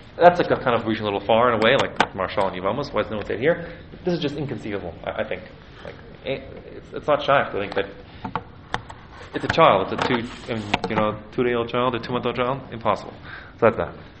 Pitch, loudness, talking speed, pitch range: 115 Hz, -23 LUFS, 240 wpm, 105-125 Hz